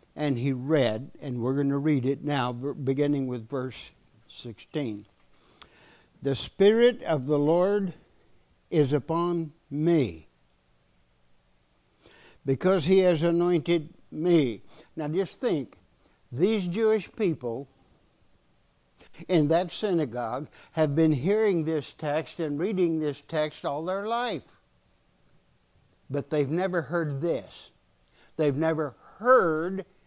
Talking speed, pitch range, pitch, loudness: 110 wpm, 135-175 Hz, 155 Hz, -27 LUFS